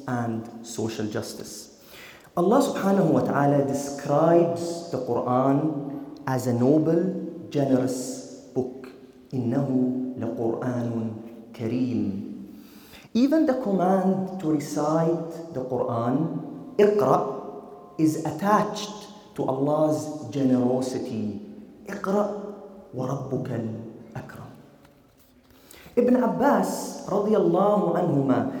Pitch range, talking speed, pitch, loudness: 125-175 Hz, 80 wpm, 140 Hz, -25 LUFS